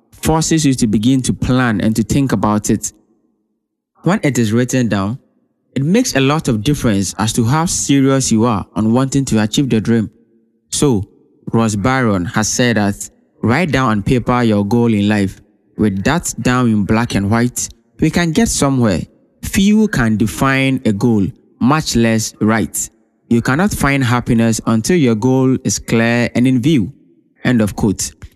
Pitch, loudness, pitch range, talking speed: 115 Hz, -15 LUFS, 110-130 Hz, 175 wpm